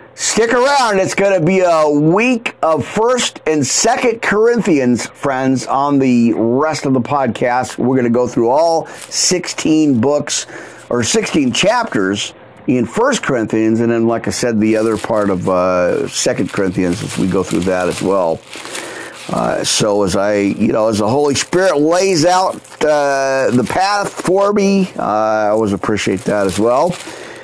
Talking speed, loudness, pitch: 170 wpm, -14 LUFS, 140 Hz